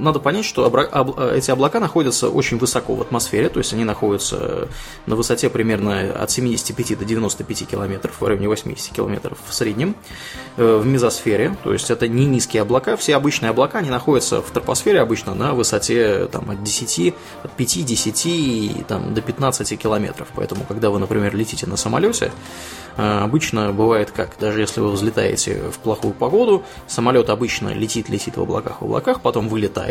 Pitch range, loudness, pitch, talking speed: 105-125 Hz, -19 LUFS, 110 Hz, 160 wpm